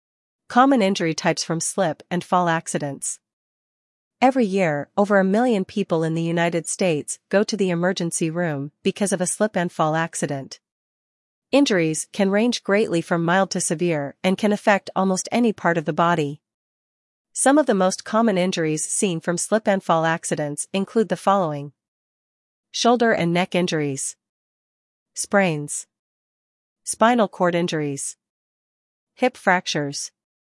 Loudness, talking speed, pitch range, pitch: -21 LUFS, 140 wpm, 165-200 Hz, 180 Hz